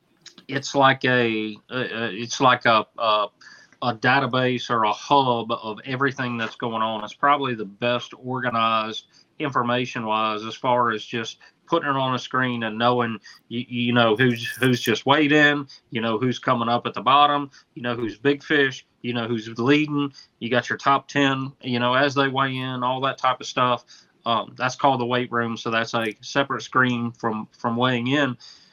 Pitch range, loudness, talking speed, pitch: 115-135 Hz, -22 LUFS, 190 wpm, 125 Hz